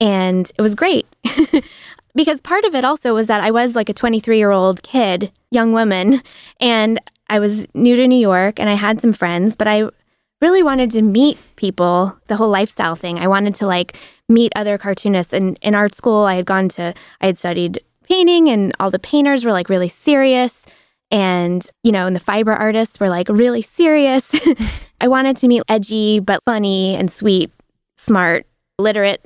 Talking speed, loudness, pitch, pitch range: 190 wpm, -15 LUFS, 215 Hz, 190-245 Hz